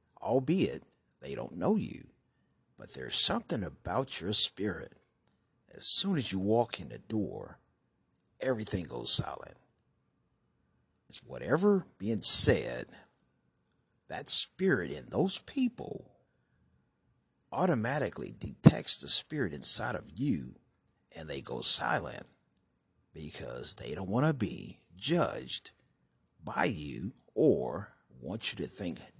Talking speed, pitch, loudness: 115 wpm, 105 Hz, -27 LUFS